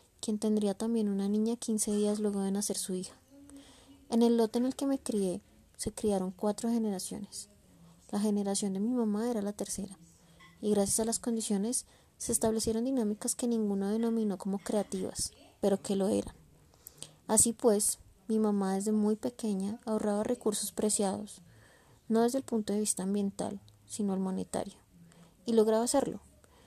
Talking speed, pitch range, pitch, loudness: 160 wpm, 195-225 Hz, 210 Hz, -32 LUFS